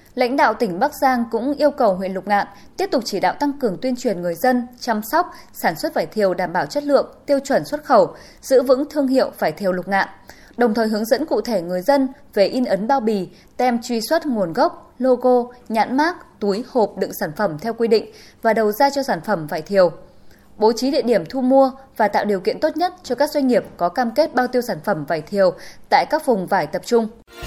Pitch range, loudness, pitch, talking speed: 200-275 Hz, -19 LUFS, 240 Hz, 245 wpm